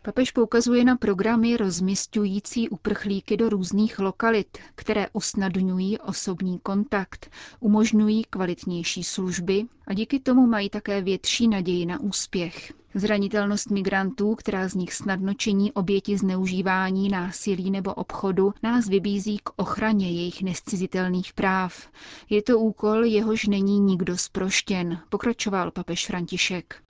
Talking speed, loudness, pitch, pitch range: 120 wpm, -24 LUFS, 200 Hz, 190-215 Hz